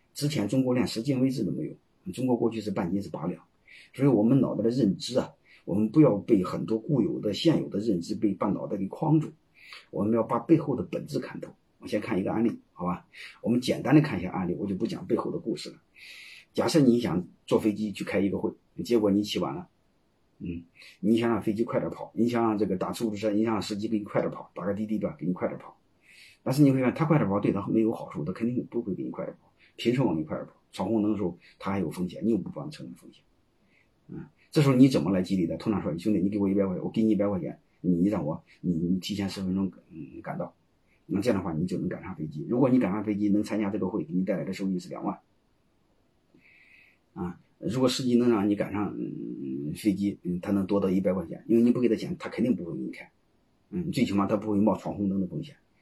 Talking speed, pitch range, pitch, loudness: 360 characters per minute, 95-115 Hz, 105 Hz, -28 LUFS